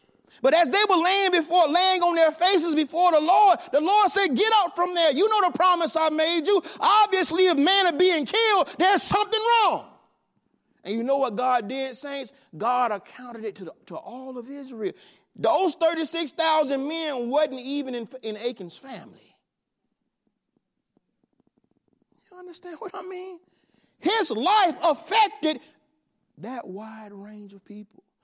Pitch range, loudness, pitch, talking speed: 250-365 Hz, -22 LUFS, 315 Hz, 160 wpm